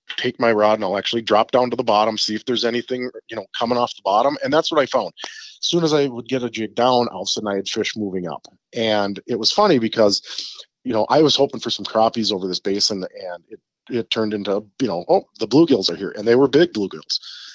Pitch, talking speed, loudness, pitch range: 110 Hz, 265 wpm, -19 LUFS, 105-125 Hz